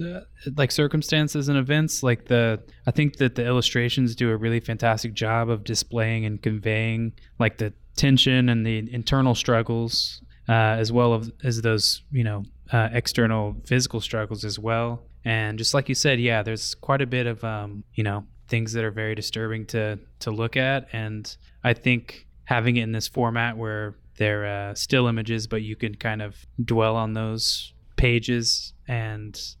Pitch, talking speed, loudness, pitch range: 115 Hz, 175 wpm, -24 LUFS, 110-120 Hz